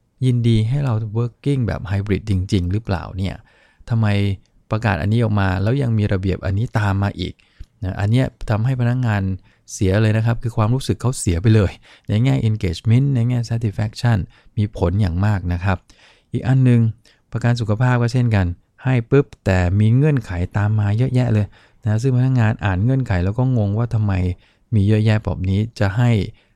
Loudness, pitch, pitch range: -19 LUFS, 110 Hz, 100-120 Hz